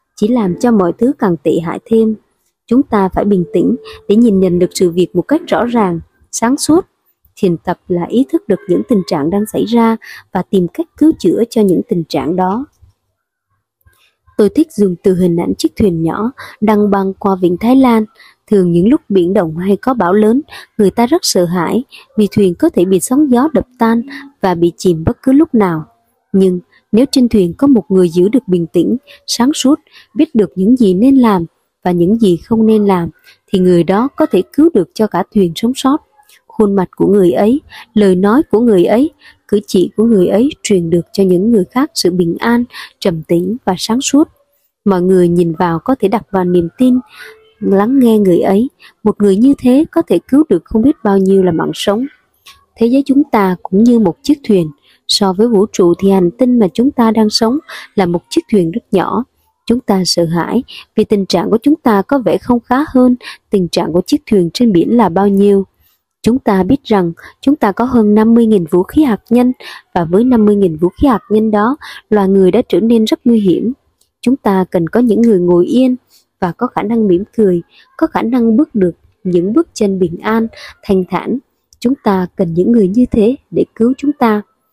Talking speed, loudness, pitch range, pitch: 215 wpm, -12 LUFS, 185-250 Hz, 215 Hz